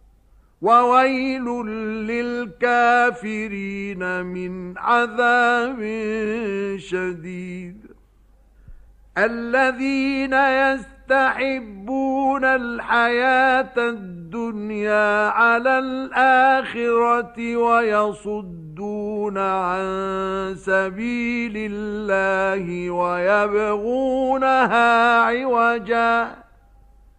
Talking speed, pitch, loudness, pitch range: 40 wpm, 230 Hz, -20 LUFS, 195-245 Hz